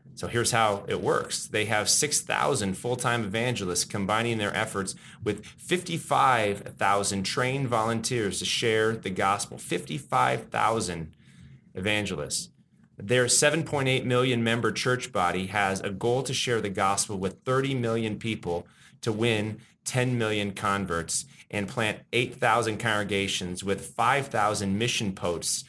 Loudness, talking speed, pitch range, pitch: -26 LUFS, 125 wpm, 100-120 Hz, 110 Hz